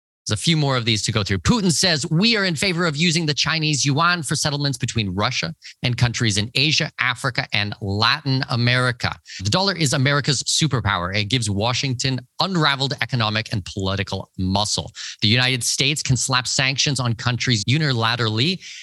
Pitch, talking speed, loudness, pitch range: 130 Hz, 170 wpm, -20 LUFS, 110-150 Hz